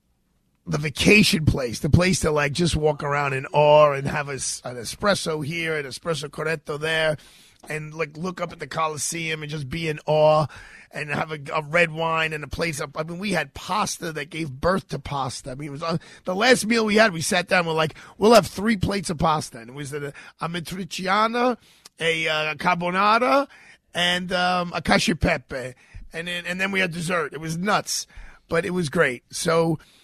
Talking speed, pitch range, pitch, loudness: 205 wpm, 150-180 Hz, 165 Hz, -22 LUFS